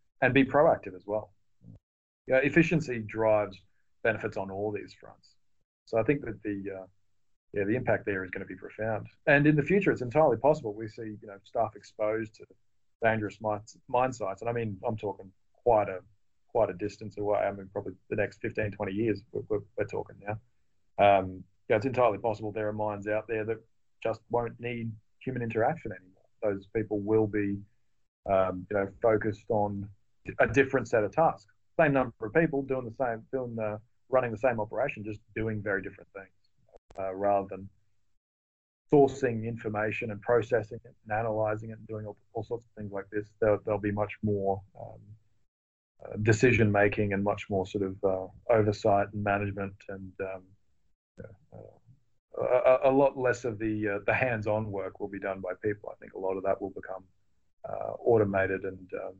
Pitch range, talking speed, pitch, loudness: 100-115 Hz, 190 wpm, 105 Hz, -29 LUFS